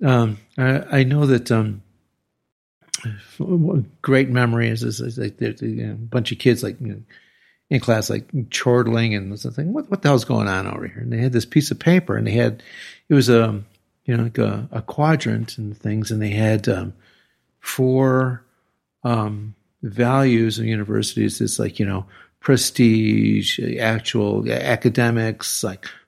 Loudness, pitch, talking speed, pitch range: -20 LUFS, 115 Hz, 170 wpm, 110-130 Hz